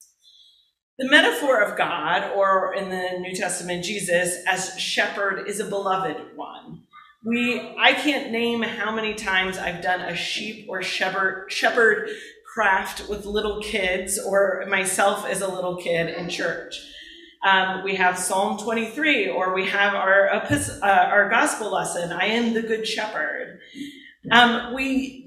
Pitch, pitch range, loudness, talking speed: 195 Hz, 185-230 Hz, -22 LUFS, 145 wpm